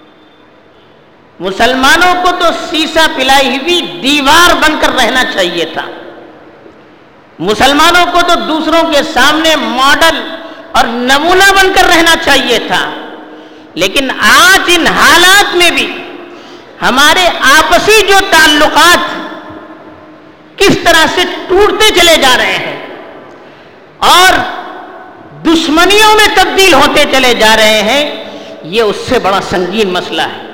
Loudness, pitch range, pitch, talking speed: -7 LUFS, 270-355 Hz, 330 Hz, 120 wpm